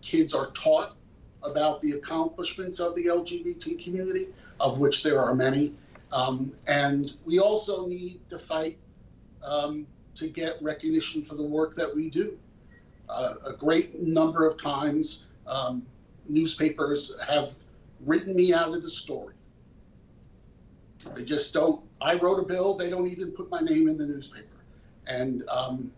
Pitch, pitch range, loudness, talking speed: 160 Hz, 145-180 Hz, -27 LUFS, 150 wpm